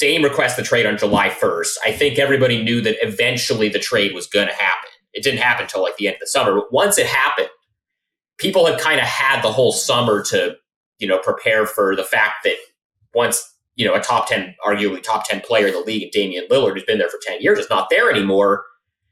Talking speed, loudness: 230 wpm, -17 LUFS